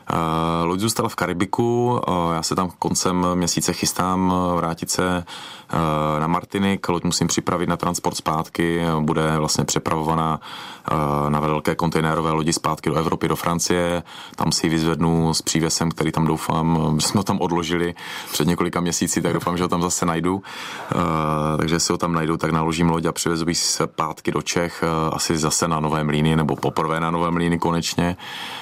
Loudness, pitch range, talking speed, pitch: -21 LUFS, 80-90 Hz, 180 wpm, 85 Hz